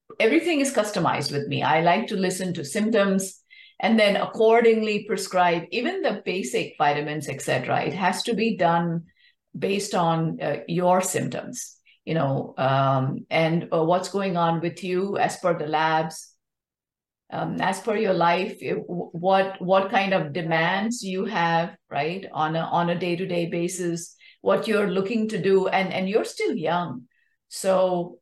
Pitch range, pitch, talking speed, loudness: 170-205 Hz, 185 Hz, 155 wpm, -24 LUFS